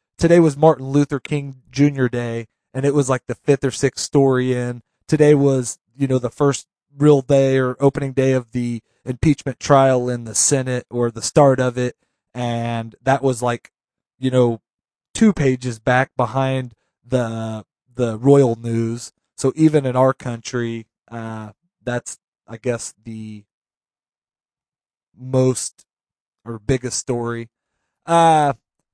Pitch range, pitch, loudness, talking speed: 120-140 Hz, 125 Hz, -18 LUFS, 145 wpm